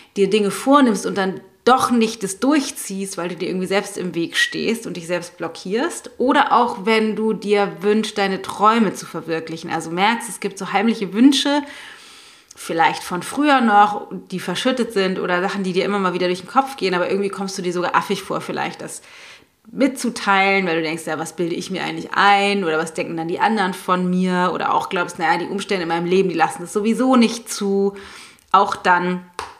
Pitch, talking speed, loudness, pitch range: 195 Hz, 210 wpm, -19 LUFS, 180-220 Hz